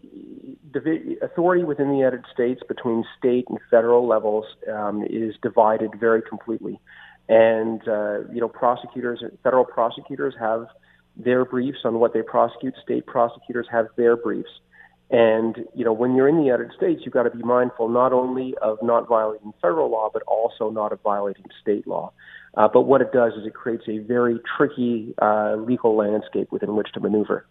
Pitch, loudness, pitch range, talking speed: 115 Hz, -22 LUFS, 110-125 Hz, 175 wpm